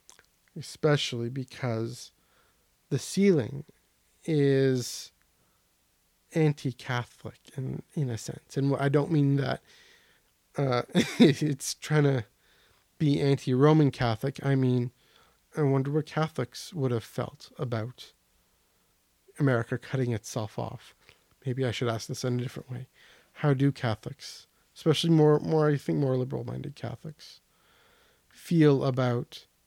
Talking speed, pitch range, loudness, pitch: 115 wpm, 120-150 Hz, -28 LUFS, 135 Hz